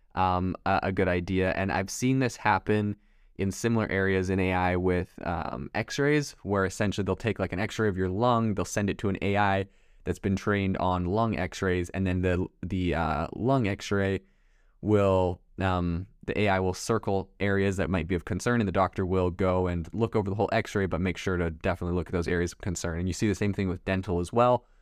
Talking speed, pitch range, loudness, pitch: 220 wpm, 90-105 Hz, -28 LUFS, 95 Hz